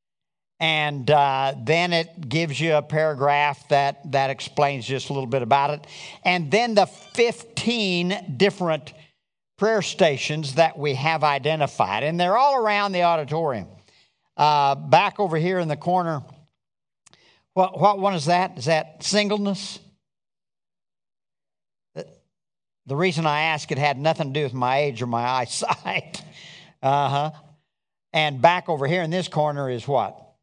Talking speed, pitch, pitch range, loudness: 150 wpm, 155 Hz, 140-175 Hz, -22 LUFS